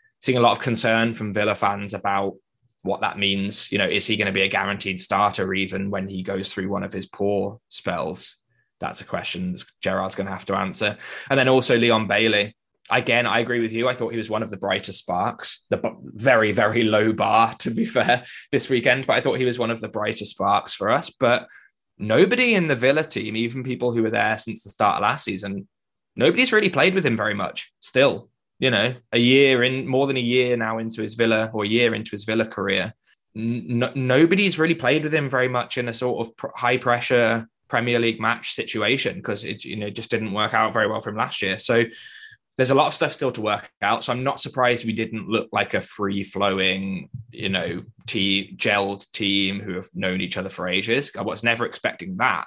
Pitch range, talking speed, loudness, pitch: 100-125 Hz, 230 wpm, -22 LUFS, 115 Hz